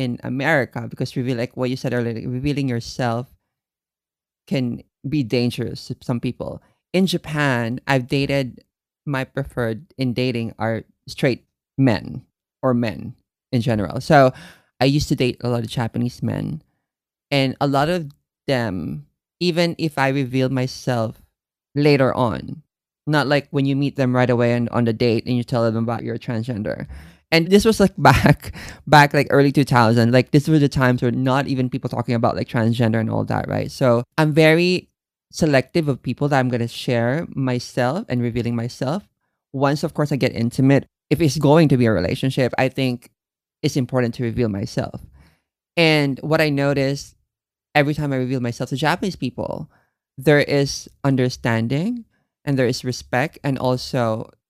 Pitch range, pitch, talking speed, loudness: 120-145 Hz, 130 Hz, 170 wpm, -20 LUFS